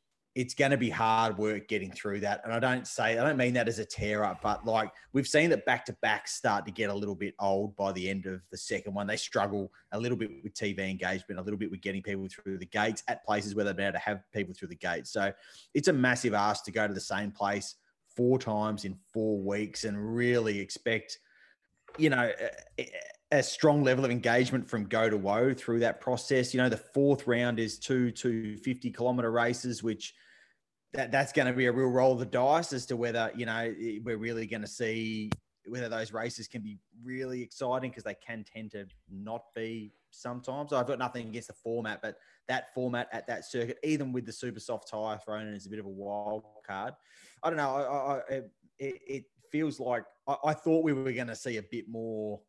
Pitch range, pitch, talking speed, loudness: 105-125 Hz, 115 Hz, 230 wpm, -32 LUFS